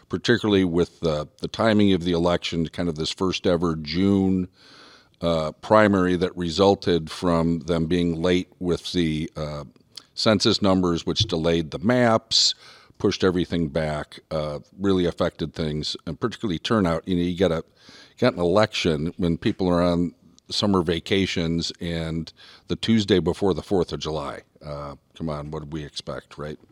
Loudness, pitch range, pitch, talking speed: -23 LUFS, 80-95 Hz, 85 Hz, 155 wpm